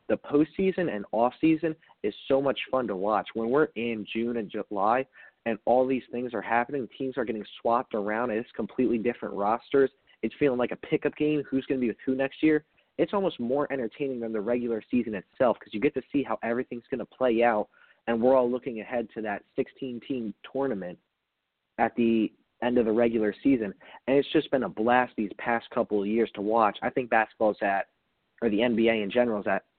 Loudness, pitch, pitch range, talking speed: -28 LUFS, 120 Hz, 110-135 Hz, 210 wpm